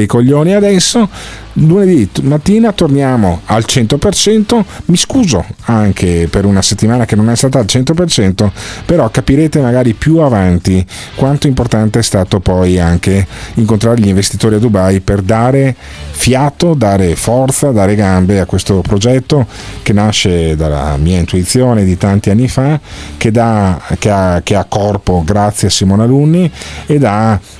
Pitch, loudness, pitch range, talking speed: 110 Hz, -10 LUFS, 95-135 Hz, 150 wpm